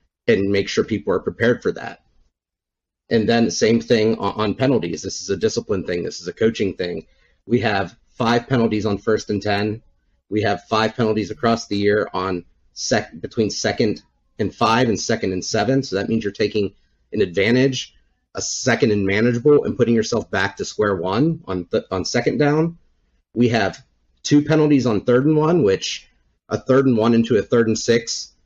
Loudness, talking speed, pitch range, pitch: -20 LUFS, 190 wpm, 95-120 Hz, 110 Hz